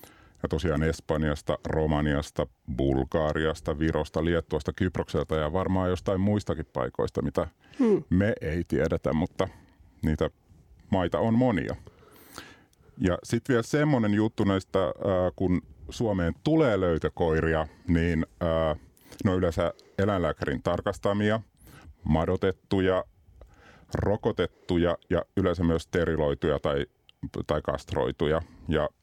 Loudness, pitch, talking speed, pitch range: -28 LUFS, 85 Hz, 95 wpm, 80-95 Hz